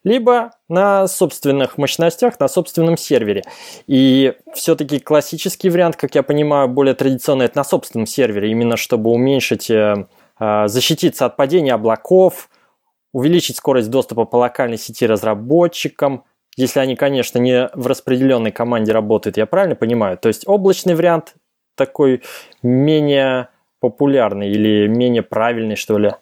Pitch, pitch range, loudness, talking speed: 135 Hz, 115-165 Hz, -16 LUFS, 130 wpm